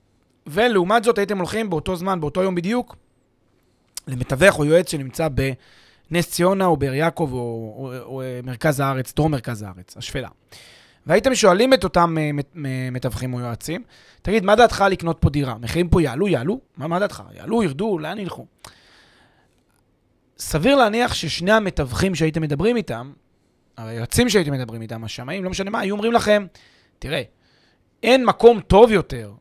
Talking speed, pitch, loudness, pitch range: 155 wpm, 160 Hz, -20 LUFS, 130-195 Hz